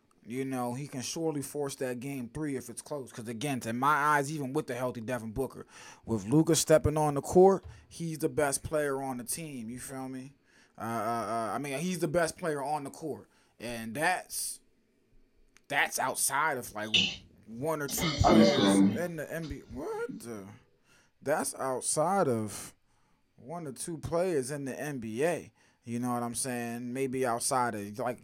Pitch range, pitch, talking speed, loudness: 120-150 Hz, 130 Hz, 180 wpm, -31 LUFS